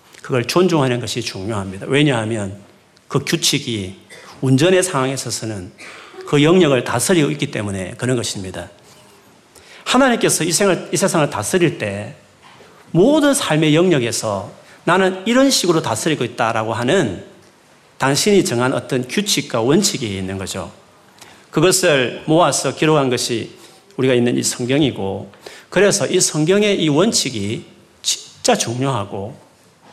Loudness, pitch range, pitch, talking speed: -17 LUFS, 110-175 Hz, 135 Hz, 285 characters per minute